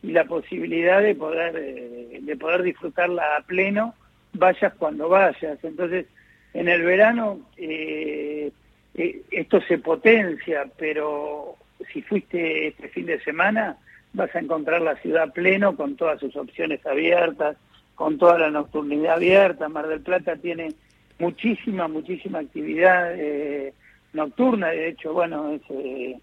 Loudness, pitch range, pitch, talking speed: -22 LUFS, 150-185 Hz, 165 Hz, 135 wpm